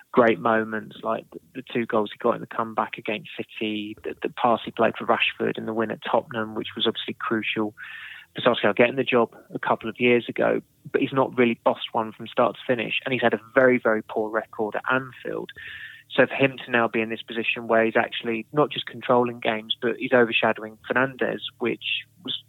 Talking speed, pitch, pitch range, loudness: 215 wpm, 115 Hz, 110-125 Hz, -24 LUFS